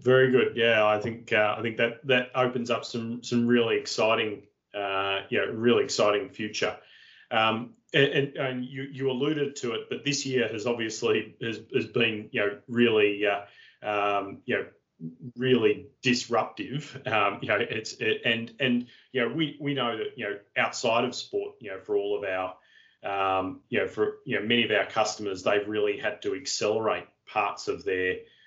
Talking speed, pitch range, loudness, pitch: 195 wpm, 110-140 Hz, -27 LUFS, 125 Hz